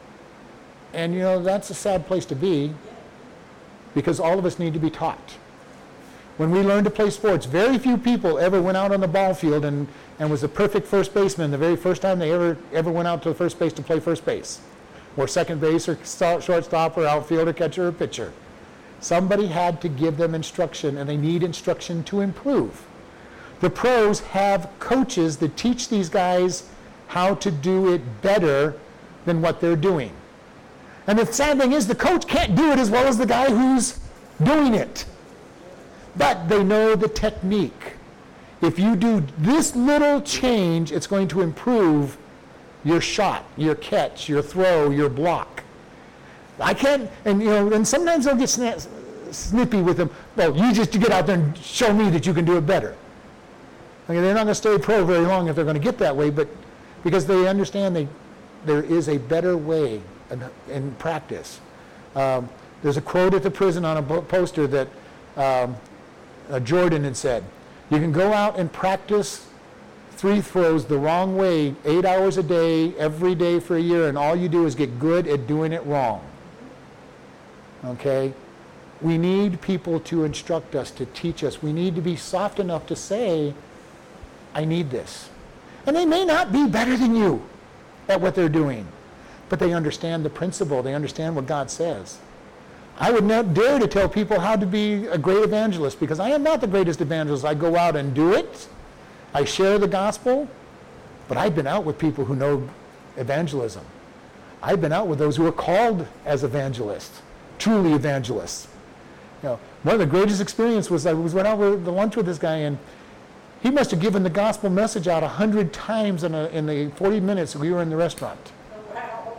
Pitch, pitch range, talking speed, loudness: 175 Hz, 155-205 Hz, 190 wpm, -22 LUFS